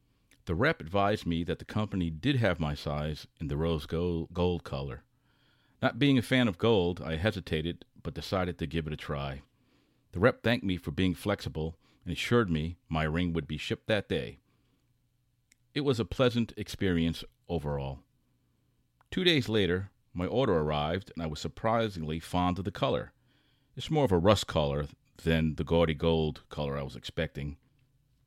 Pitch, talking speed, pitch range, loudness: 90 Hz, 175 wpm, 80-120 Hz, -31 LUFS